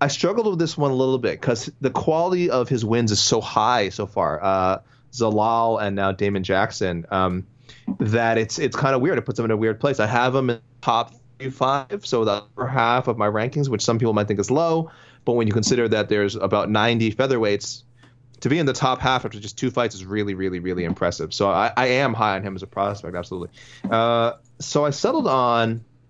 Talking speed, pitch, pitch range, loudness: 230 wpm, 115 Hz, 105-130 Hz, -21 LUFS